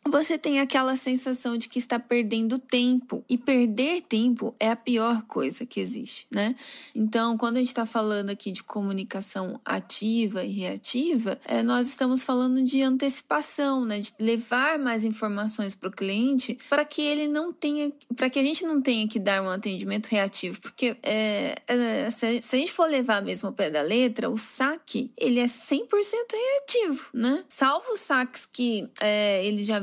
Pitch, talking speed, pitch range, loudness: 245 Hz, 170 wpm, 220-275 Hz, -26 LUFS